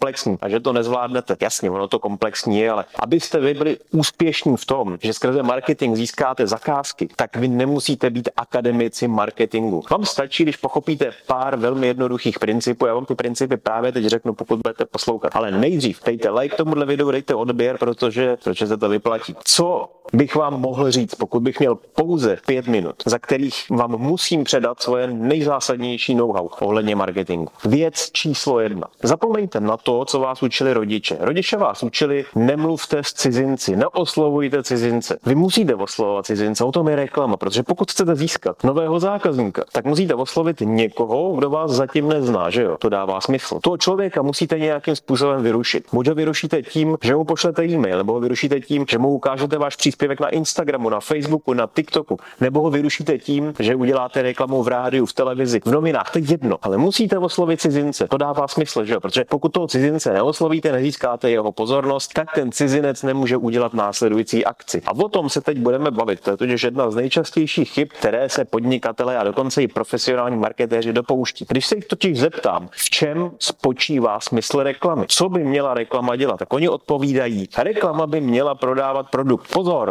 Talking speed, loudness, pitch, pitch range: 180 wpm, -19 LUFS, 135 Hz, 120-150 Hz